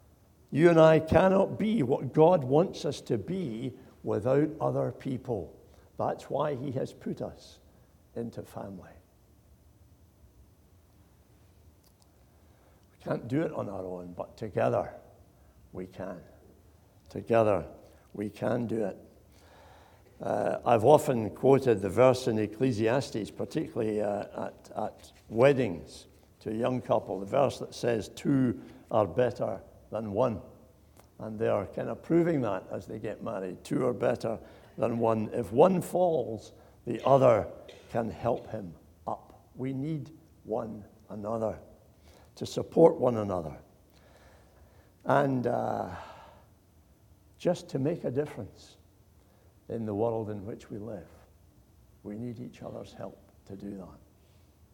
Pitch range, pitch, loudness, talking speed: 95-125 Hz, 105 Hz, -29 LUFS, 130 wpm